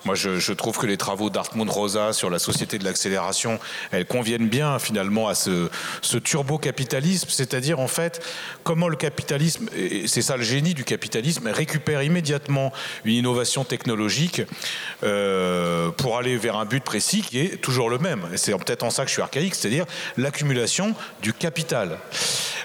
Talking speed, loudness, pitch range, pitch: 170 wpm, -23 LUFS, 110-160 Hz, 135 Hz